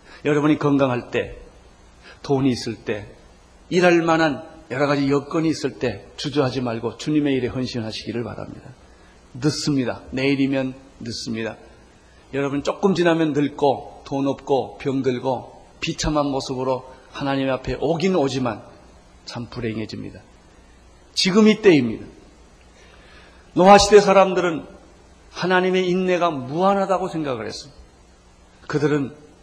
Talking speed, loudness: 280 characters per minute, -21 LUFS